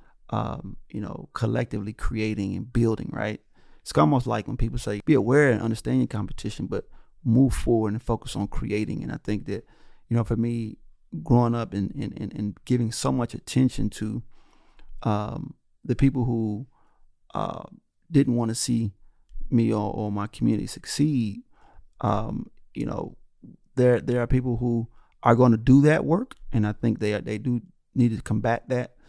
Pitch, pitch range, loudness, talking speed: 115 Hz, 105-125 Hz, -25 LUFS, 170 wpm